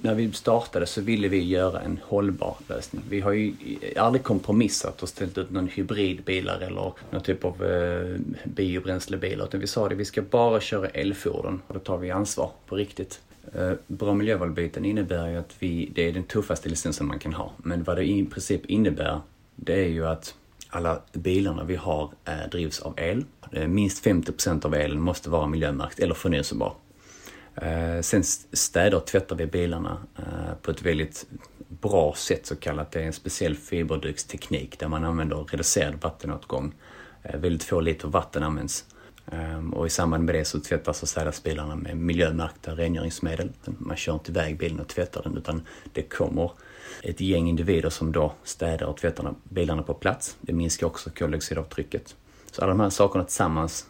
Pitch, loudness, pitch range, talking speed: 85 Hz, -27 LUFS, 80-95 Hz, 175 wpm